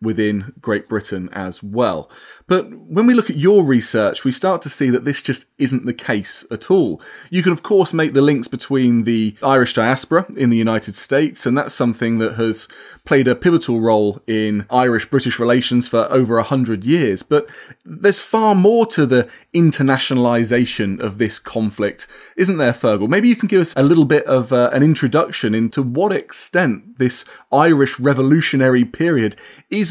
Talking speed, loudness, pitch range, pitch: 180 wpm, -16 LUFS, 115-160 Hz, 130 Hz